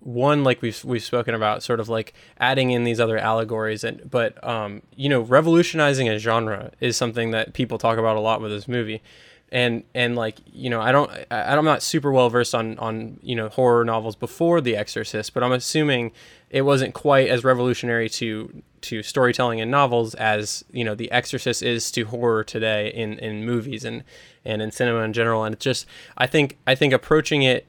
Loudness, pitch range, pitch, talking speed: -22 LUFS, 110-130 Hz, 120 Hz, 205 wpm